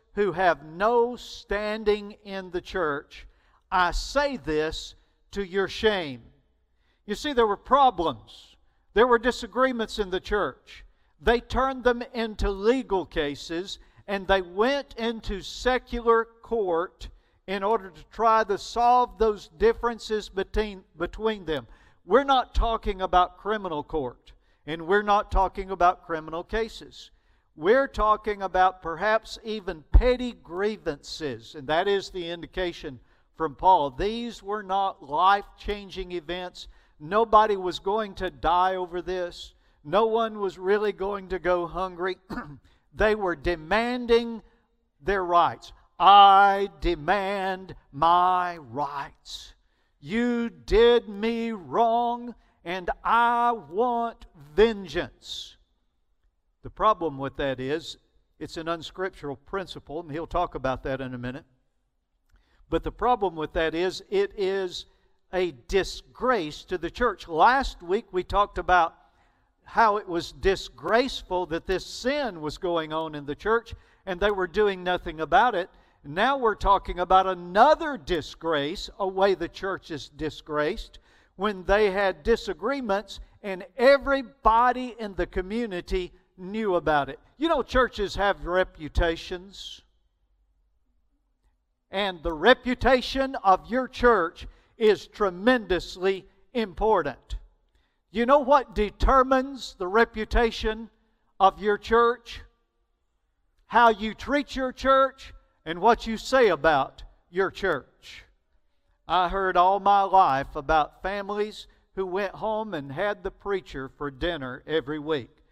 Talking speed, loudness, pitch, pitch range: 125 wpm, -25 LUFS, 195 Hz, 170-225 Hz